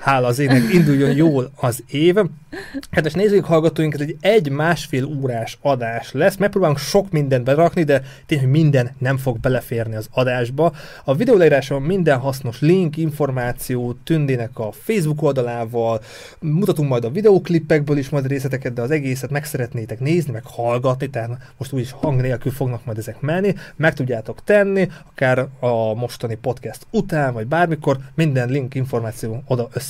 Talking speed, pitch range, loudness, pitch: 160 wpm, 125-160 Hz, -19 LUFS, 135 Hz